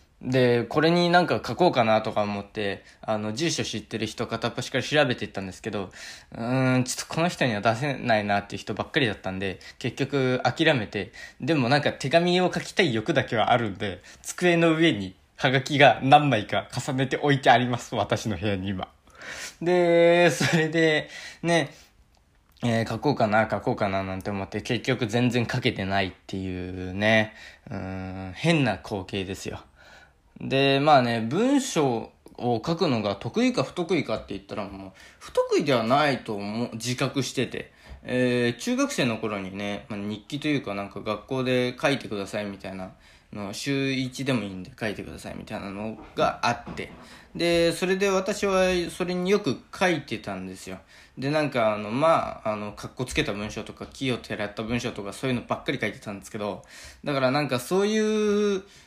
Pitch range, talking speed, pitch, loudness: 105-150 Hz, 355 characters per minute, 125 Hz, -25 LUFS